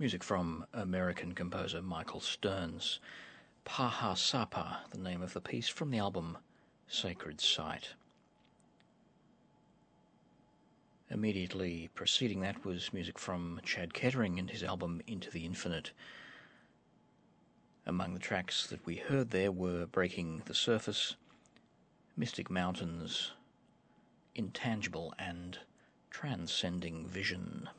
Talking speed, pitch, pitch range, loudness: 105 wpm, 90 Hz, 85-95 Hz, -37 LUFS